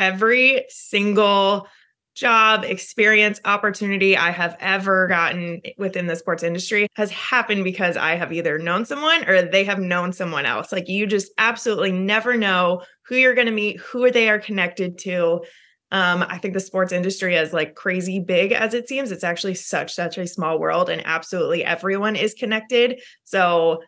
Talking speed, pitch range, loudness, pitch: 175 wpm, 180-215 Hz, -19 LUFS, 195 Hz